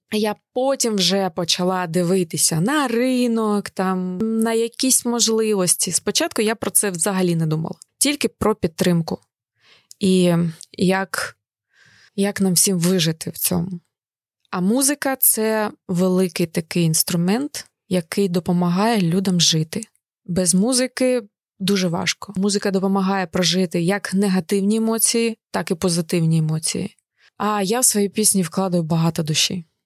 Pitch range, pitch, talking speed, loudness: 175-215 Hz, 190 Hz, 125 wpm, -19 LUFS